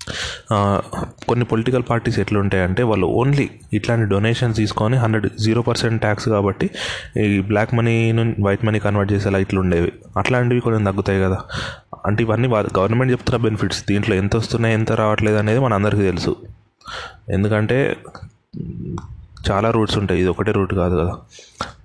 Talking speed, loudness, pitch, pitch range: 135 wpm, -19 LUFS, 105 Hz, 100-115 Hz